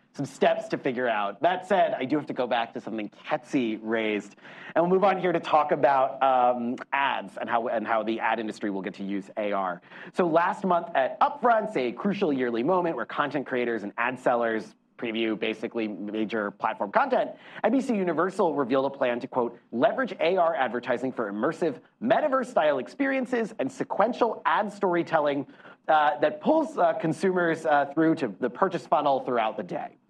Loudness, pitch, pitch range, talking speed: -26 LUFS, 145 Hz, 115-185 Hz, 180 wpm